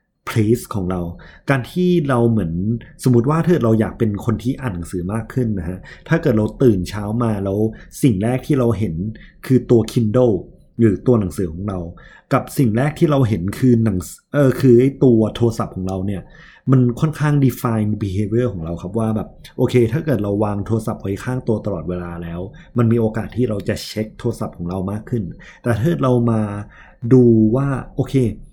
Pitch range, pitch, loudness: 100-130 Hz, 115 Hz, -18 LUFS